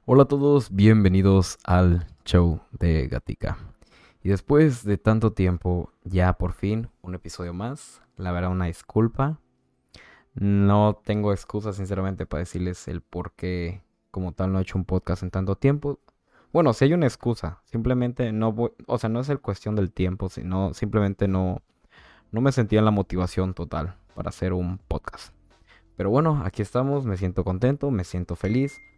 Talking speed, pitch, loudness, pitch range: 170 wpm, 95 Hz, -24 LUFS, 90-115 Hz